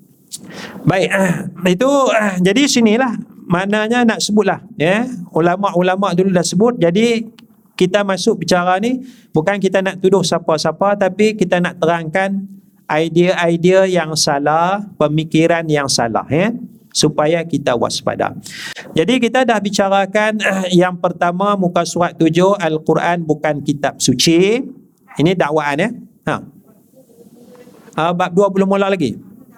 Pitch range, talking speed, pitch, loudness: 170-215 Hz, 115 wpm, 190 Hz, -15 LUFS